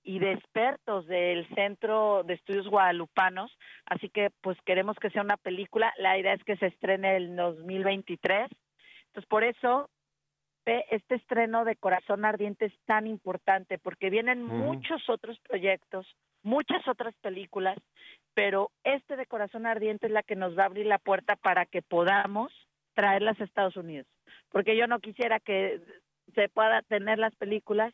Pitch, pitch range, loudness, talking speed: 205 Hz, 190-225 Hz, -29 LUFS, 160 wpm